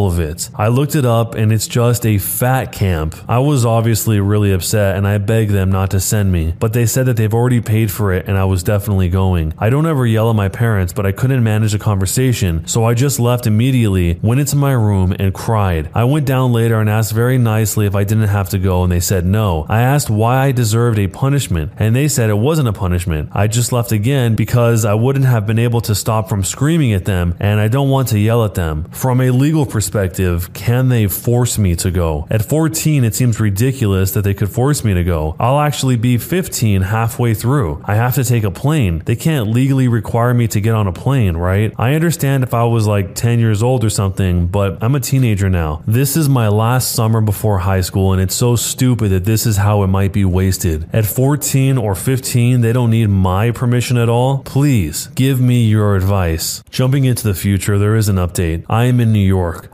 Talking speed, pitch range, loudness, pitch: 230 wpm, 100-125 Hz, -15 LUFS, 110 Hz